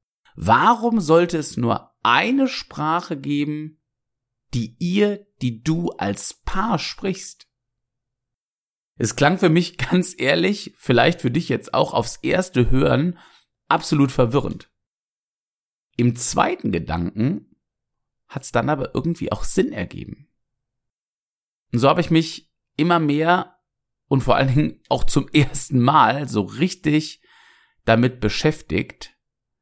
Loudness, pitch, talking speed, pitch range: -20 LUFS, 145 Hz, 120 wpm, 125-170 Hz